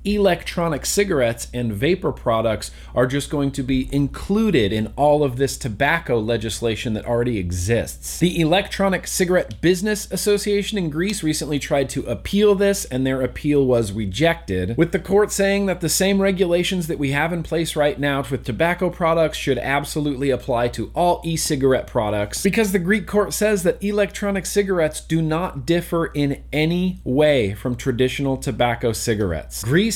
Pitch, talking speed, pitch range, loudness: 150 Hz, 160 wpm, 125-185 Hz, -20 LUFS